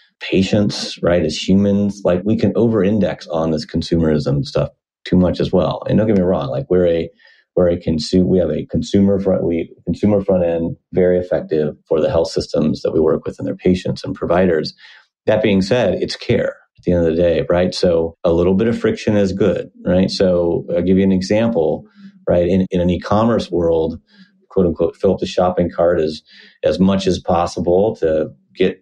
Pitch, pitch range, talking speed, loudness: 90 Hz, 85-100 Hz, 205 wpm, -17 LUFS